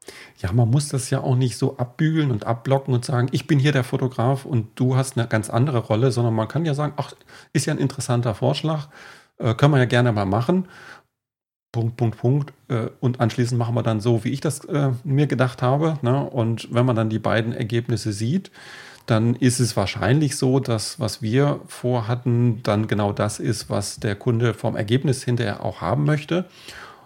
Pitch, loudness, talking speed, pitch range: 125 Hz, -22 LUFS, 200 wpm, 115-135 Hz